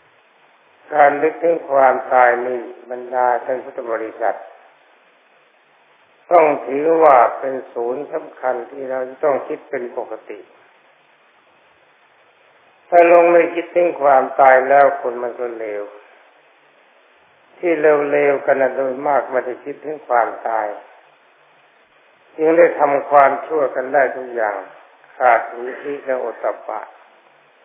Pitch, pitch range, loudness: 140 Hz, 130-155 Hz, -17 LUFS